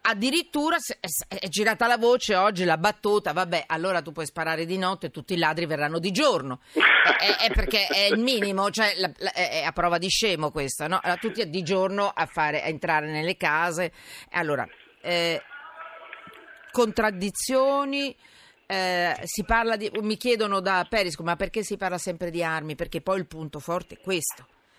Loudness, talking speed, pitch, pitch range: -25 LUFS, 170 wpm, 185 Hz, 170-215 Hz